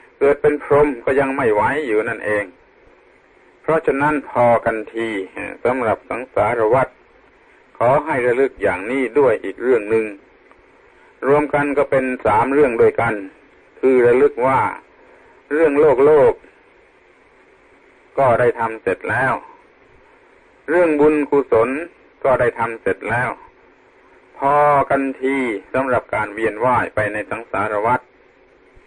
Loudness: -17 LUFS